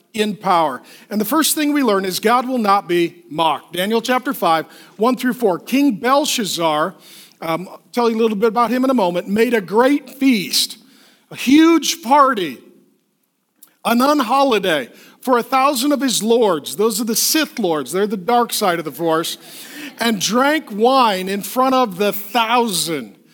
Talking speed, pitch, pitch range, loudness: 175 wpm, 235 Hz, 195-260 Hz, -17 LUFS